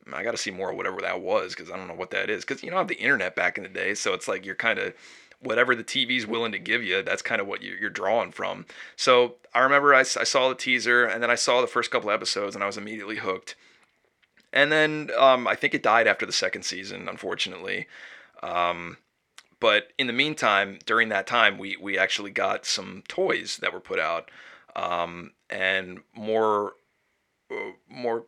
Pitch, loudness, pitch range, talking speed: 115 Hz, -24 LUFS, 100-135 Hz, 220 wpm